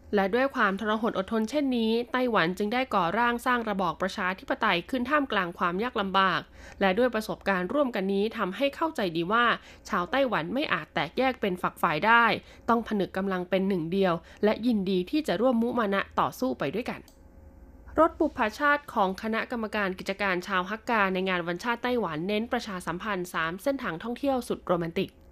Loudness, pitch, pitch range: -27 LUFS, 210 Hz, 190-245 Hz